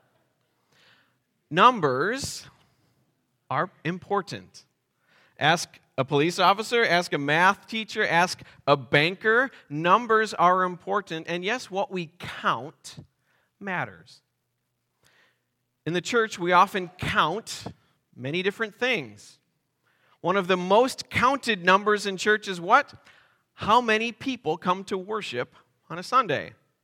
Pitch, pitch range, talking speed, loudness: 185 Hz, 160-215 Hz, 115 wpm, -24 LUFS